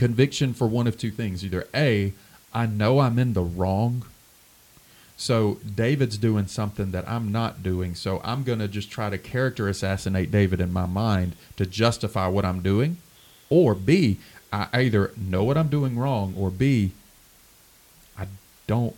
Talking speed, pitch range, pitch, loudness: 170 wpm, 95-120 Hz, 105 Hz, -24 LUFS